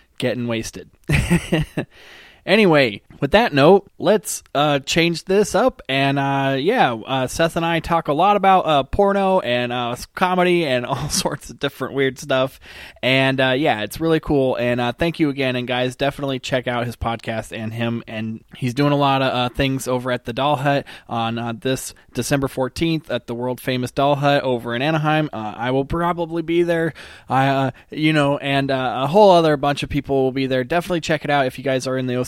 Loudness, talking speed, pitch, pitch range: -19 LUFS, 210 wpm, 135 Hz, 125-160 Hz